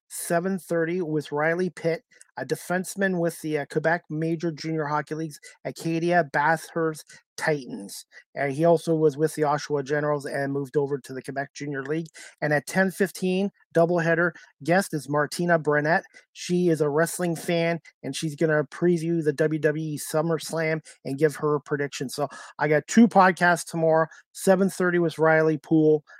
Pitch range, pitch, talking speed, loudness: 150-170 Hz, 160 Hz, 160 wpm, -25 LUFS